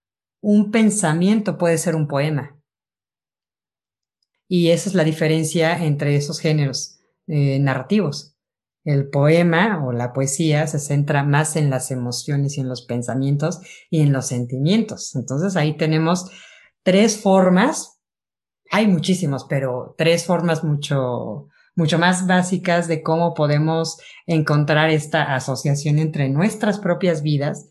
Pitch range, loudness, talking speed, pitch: 140-175 Hz, -19 LUFS, 130 wpm, 155 Hz